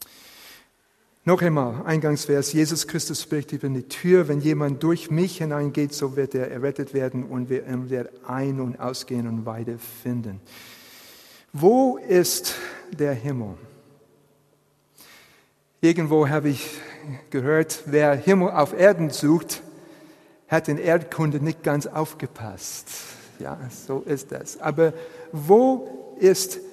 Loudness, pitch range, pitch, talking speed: -23 LUFS, 130-160 Hz, 145 Hz, 120 wpm